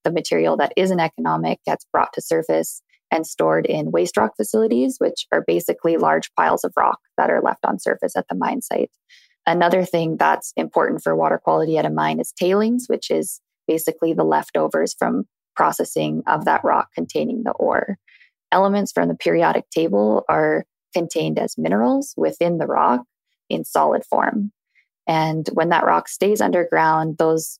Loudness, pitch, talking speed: -20 LUFS, 160 Hz, 170 wpm